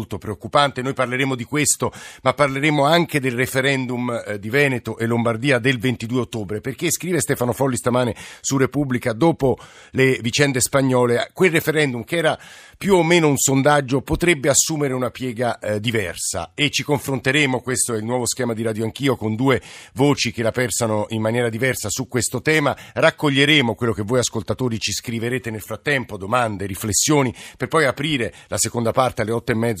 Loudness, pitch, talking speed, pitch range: -20 LUFS, 125 Hz, 175 wpm, 115-140 Hz